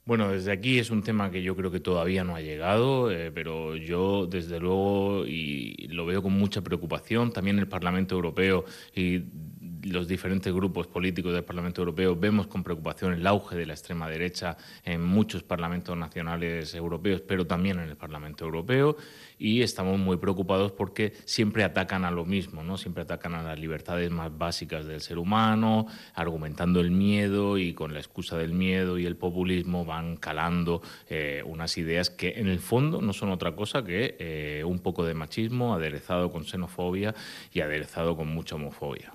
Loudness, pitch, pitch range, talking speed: -29 LUFS, 90 Hz, 85-100 Hz, 180 wpm